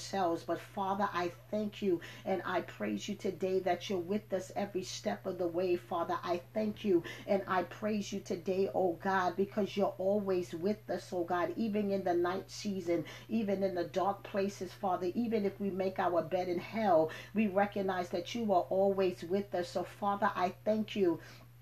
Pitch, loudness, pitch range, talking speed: 190 Hz, -35 LUFS, 175-200 Hz, 190 wpm